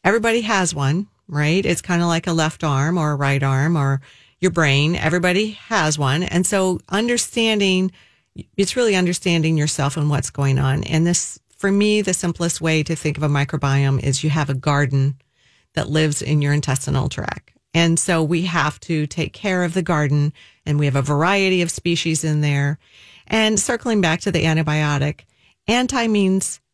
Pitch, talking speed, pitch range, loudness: 160 Hz, 185 wpm, 145-185 Hz, -19 LUFS